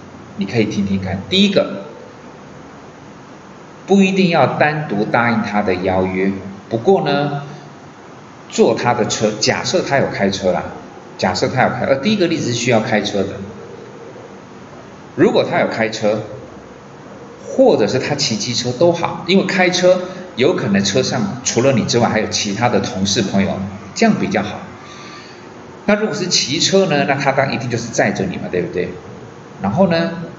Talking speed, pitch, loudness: 235 characters per minute, 125 Hz, -16 LUFS